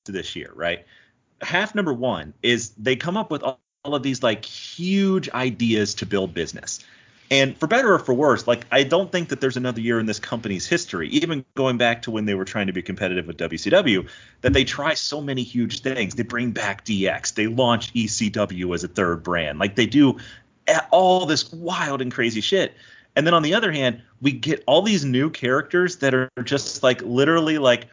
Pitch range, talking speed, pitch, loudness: 110-145 Hz, 205 wpm, 125 Hz, -21 LUFS